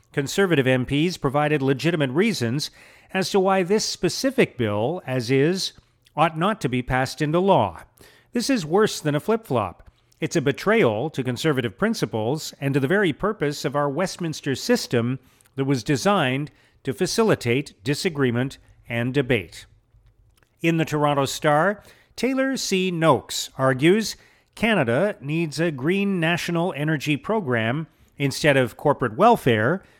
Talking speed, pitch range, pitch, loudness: 140 wpm, 130-185 Hz, 150 Hz, -22 LUFS